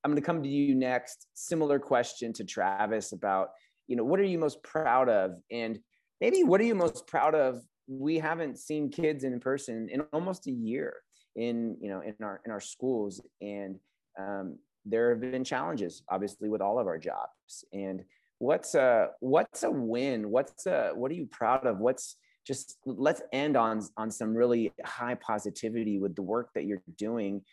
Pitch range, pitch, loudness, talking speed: 105-150 Hz, 120 Hz, -31 LUFS, 190 wpm